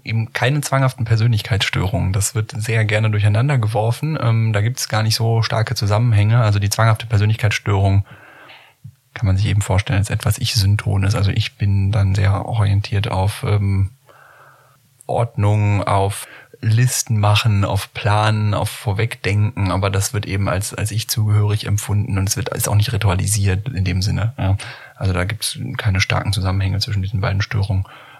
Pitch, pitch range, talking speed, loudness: 105 Hz, 100-115 Hz, 165 wpm, -18 LUFS